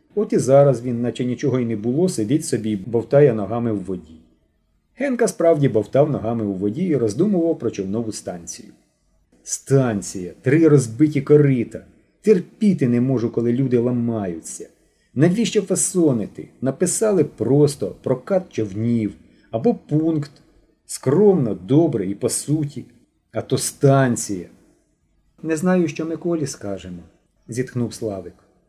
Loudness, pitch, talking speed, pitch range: -20 LUFS, 130 Hz, 125 wpm, 110-160 Hz